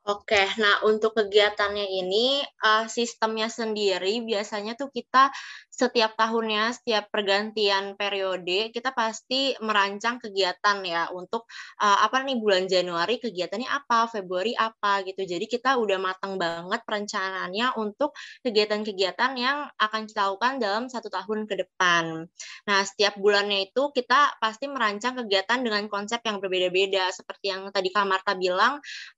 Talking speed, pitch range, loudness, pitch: 140 wpm, 195-230 Hz, -25 LUFS, 210 Hz